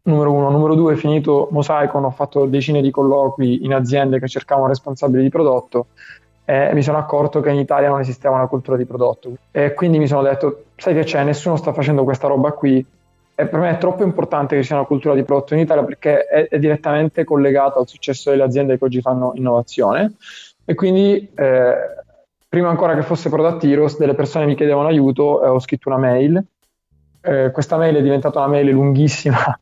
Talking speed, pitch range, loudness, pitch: 205 wpm, 135-150 Hz, -16 LUFS, 145 Hz